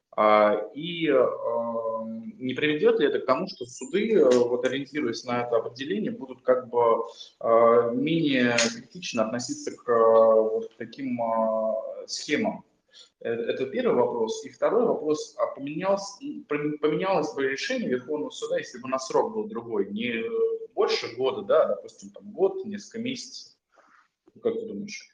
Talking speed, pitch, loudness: 130 wpm, 165 Hz, -26 LUFS